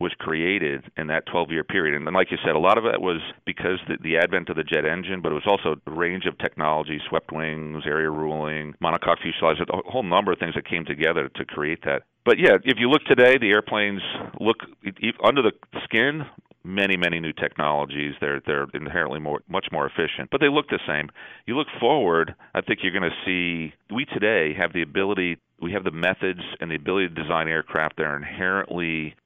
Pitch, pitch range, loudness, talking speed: 80 Hz, 75-95 Hz, -23 LUFS, 215 wpm